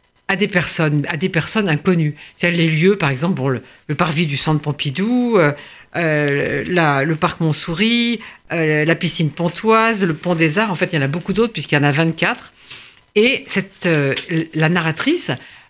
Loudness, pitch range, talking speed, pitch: -17 LUFS, 150-195 Hz, 195 wpm, 165 Hz